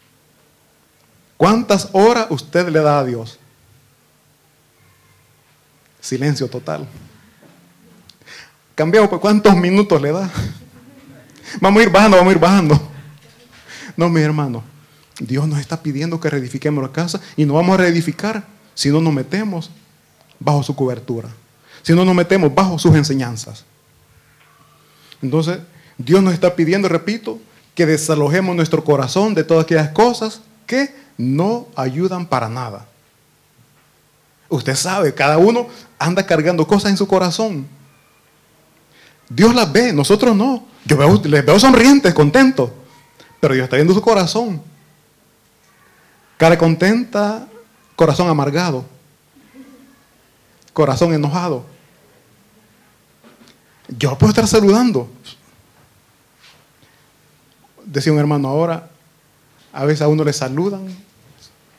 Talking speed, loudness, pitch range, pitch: 115 wpm, -15 LUFS, 145-195 Hz, 165 Hz